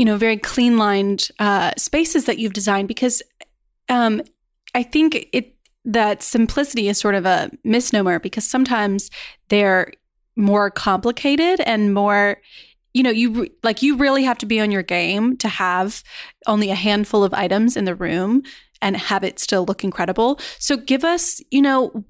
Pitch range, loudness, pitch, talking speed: 200-255 Hz, -18 LUFS, 220 Hz, 170 wpm